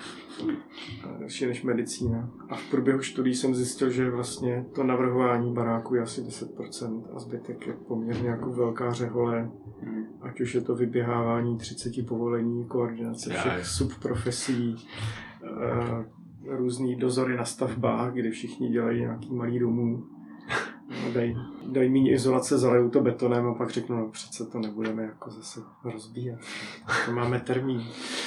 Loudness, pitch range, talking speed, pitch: -29 LUFS, 115-125 Hz, 140 wpm, 120 Hz